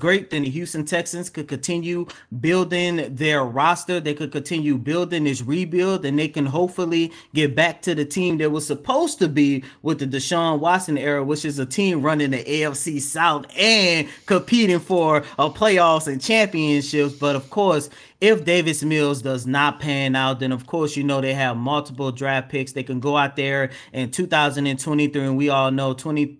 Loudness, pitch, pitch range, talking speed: -21 LUFS, 150 Hz, 140-170 Hz, 185 wpm